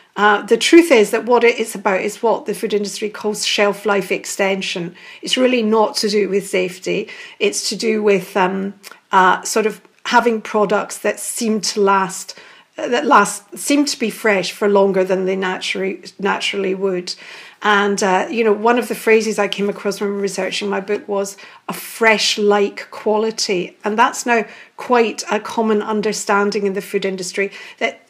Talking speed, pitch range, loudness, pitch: 185 wpm, 200-225 Hz, -17 LUFS, 210 Hz